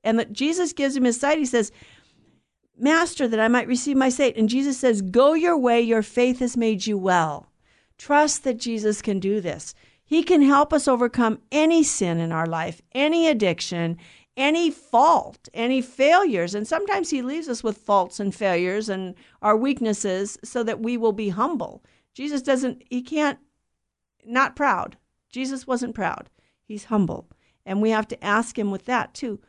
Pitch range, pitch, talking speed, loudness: 210-280 Hz, 240 Hz, 180 wpm, -22 LUFS